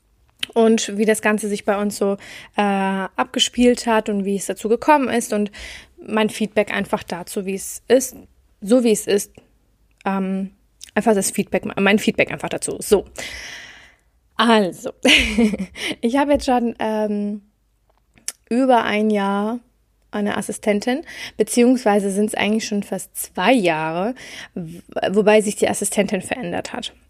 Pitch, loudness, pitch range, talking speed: 215 Hz, -19 LUFS, 200-230 Hz, 140 wpm